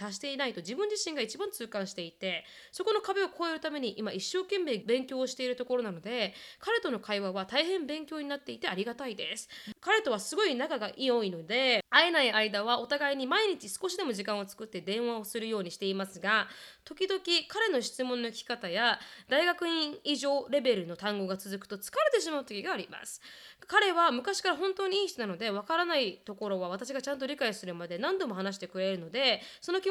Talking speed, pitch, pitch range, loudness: 420 characters per minute, 255 Hz, 205-335 Hz, -31 LUFS